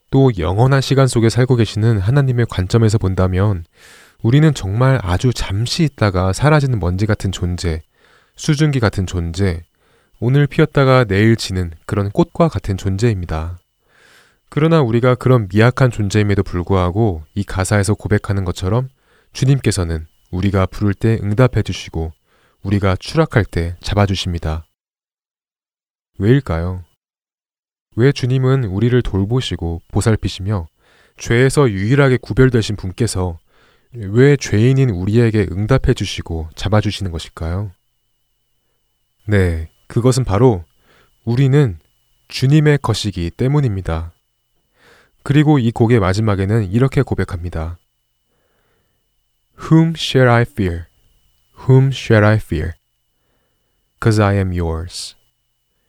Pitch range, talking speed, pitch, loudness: 95-125 Hz, 295 characters per minute, 105 Hz, -16 LUFS